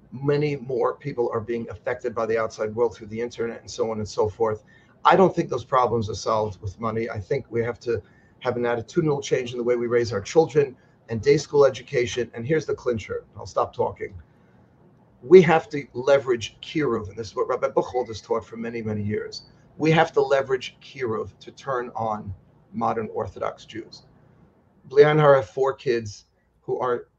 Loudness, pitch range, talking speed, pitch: -24 LUFS, 115-145 Hz, 195 wpm, 120 Hz